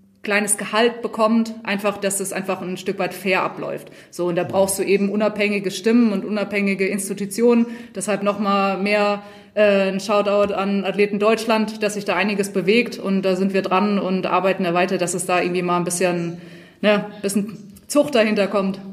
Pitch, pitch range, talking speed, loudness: 200 Hz, 190-210 Hz, 185 wpm, -20 LUFS